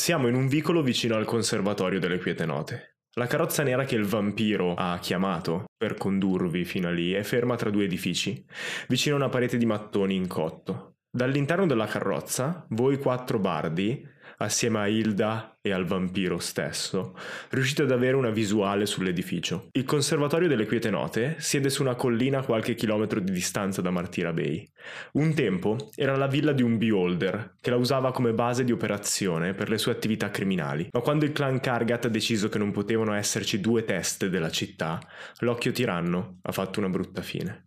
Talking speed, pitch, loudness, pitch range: 180 wpm, 115 Hz, -27 LUFS, 100-130 Hz